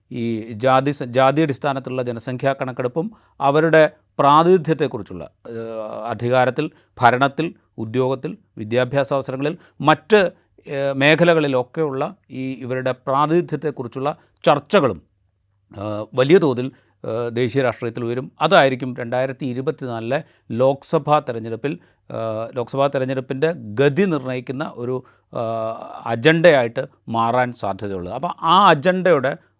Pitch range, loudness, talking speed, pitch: 120-150 Hz, -19 LUFS, 85 wpm, 130 Hz